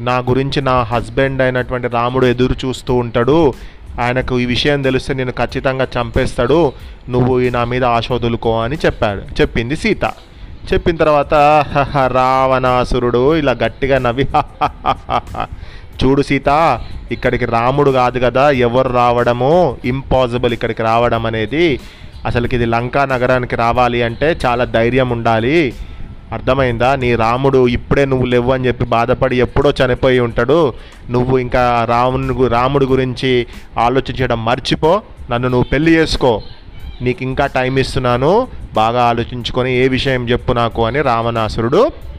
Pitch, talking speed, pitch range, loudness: 125 Hz, 125 wpm, 120-130 Hz, -14 LUFS